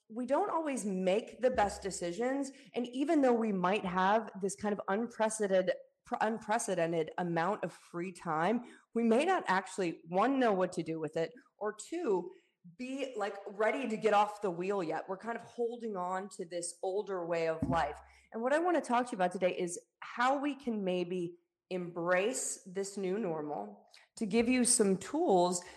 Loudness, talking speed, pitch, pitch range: -34 LUFS, 185 wpm, 205 Hz, 180-235 Hz